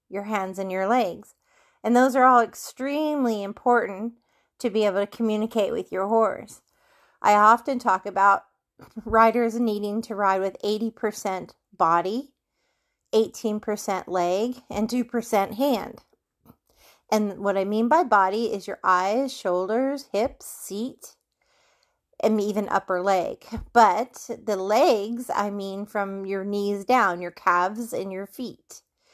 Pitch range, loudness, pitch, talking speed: 195-240 Hz, -24 LUFS, 215 Hz, 135 wpm